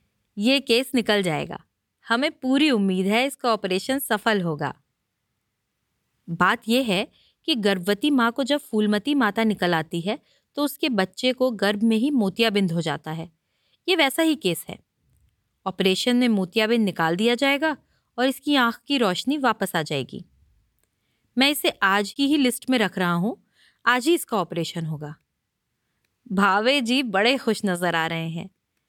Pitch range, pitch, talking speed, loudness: 180-260 Hz, 220 Hz, 160 wpm, -22 LUFS